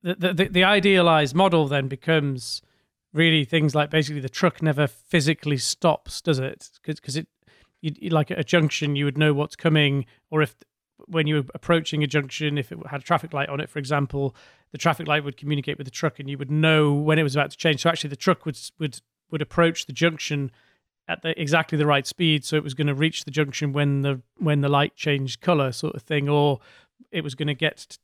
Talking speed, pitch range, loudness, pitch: 230 wpm, 145-160 Hz, -23 LUFS, 150 Hz